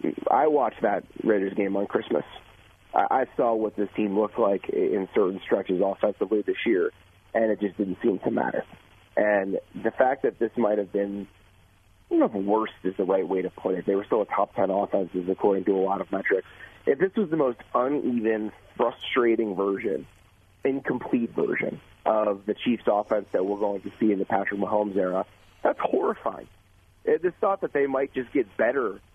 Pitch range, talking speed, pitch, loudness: 100-130 Hz, 190 wpm, 105 Hz, -26 LUFS